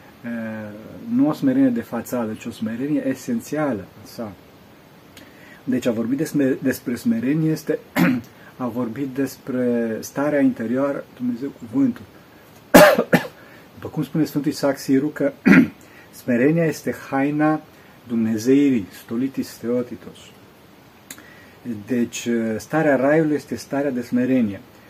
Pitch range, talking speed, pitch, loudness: 120-155 Hz, 110 wpm, 135 Hz, -21 LUFS